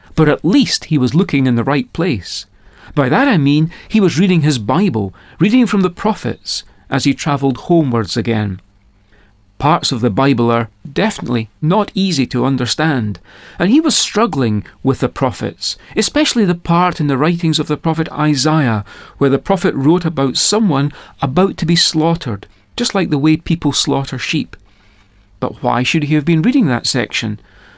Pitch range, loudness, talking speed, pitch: 120-175 Hz, -15 LUFS, 175 wpm, 145 Hz